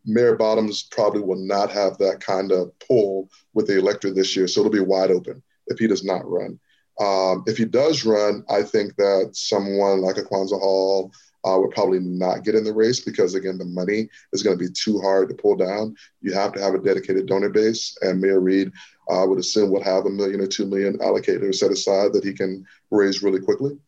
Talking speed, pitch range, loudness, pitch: 225 wpm, 95-110 Hz, -21 LUFS, 100 Hz